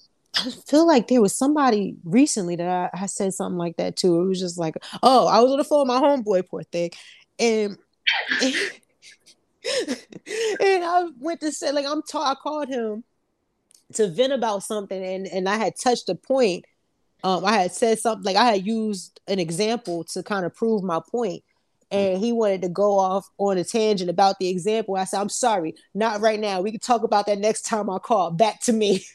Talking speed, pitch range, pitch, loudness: 210 wpm, 190-250 Hz, 210 Hz, -22 LUFS